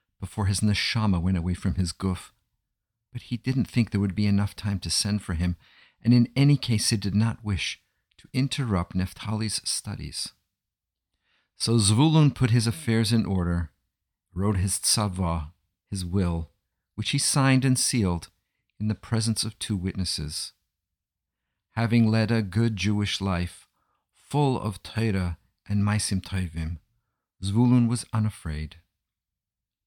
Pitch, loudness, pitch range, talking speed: 100 Hz, -25 LUFS, 90-115 Hz, 145 wpm